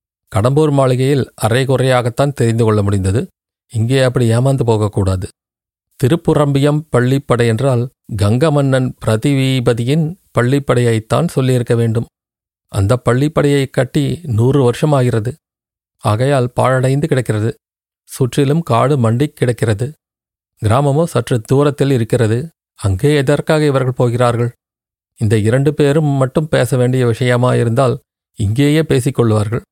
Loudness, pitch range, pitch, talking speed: -14 LUFS, 115-140 Hz, 125 Hz, 95 wpm